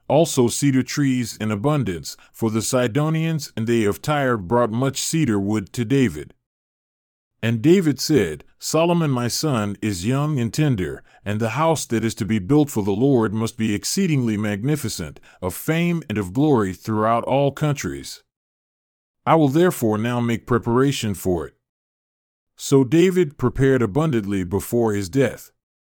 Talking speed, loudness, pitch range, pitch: 150 wpm, -21 LUFS, 105-145 Hz, 120 Hz